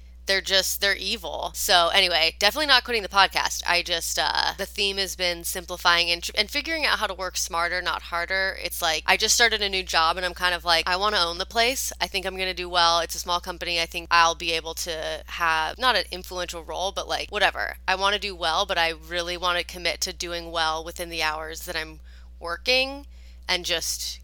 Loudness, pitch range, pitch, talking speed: -23 LUFS, 165-190 Hz, 175 Hz, 240 wpm